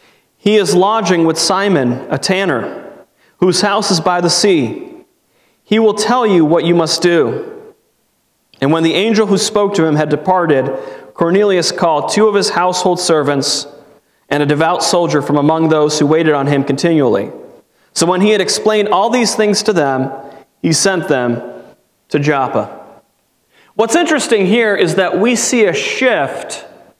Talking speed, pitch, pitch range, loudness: 165 wpm, 185 Hz, 155-215 Hz, -13 LUFS